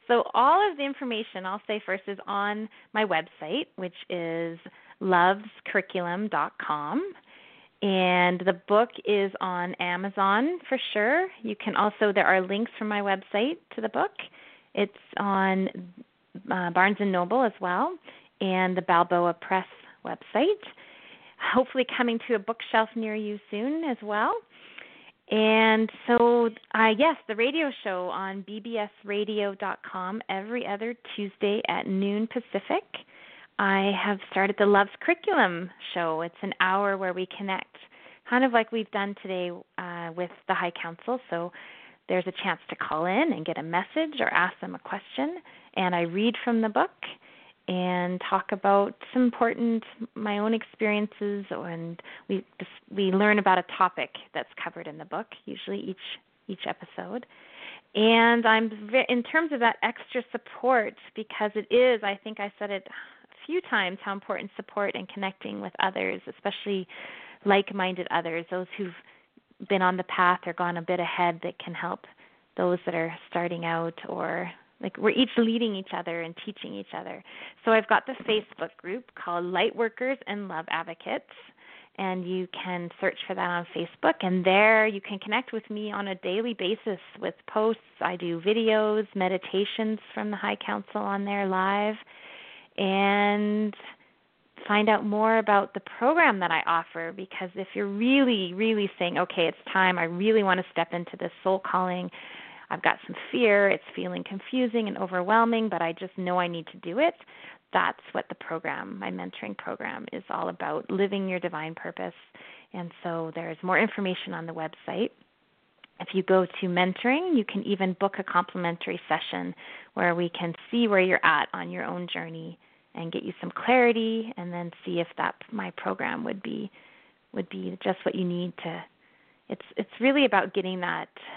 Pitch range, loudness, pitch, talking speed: 180-225 Hz, -27 LUFS, 200 Hz, 165 wpm